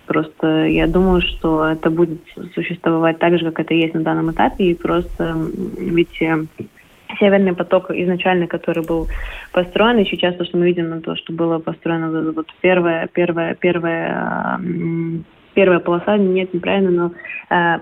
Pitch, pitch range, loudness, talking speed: 170 Hz, 165-180 Hz, -18 LUFS, 160 wpm